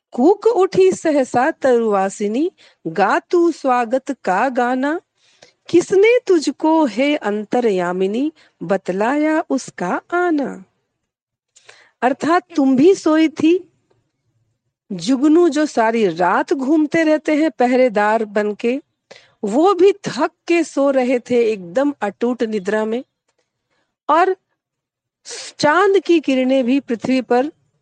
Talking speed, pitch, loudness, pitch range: 100 wpm, 270 Hz, -17 LUFS, 225-320 Hz